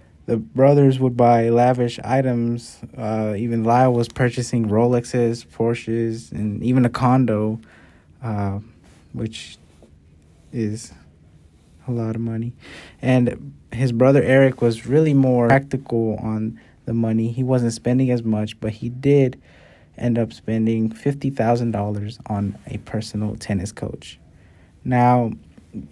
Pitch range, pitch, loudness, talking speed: 105-125 Hz, 115 Hz, -20 LUFS, 125 wpm